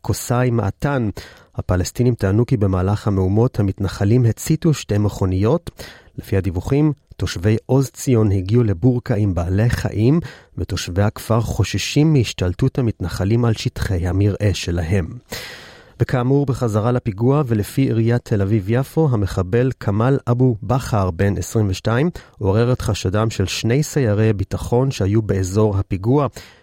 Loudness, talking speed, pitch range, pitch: -19 LUFS, 120 wpm, 100-125 Hz, 110 Hz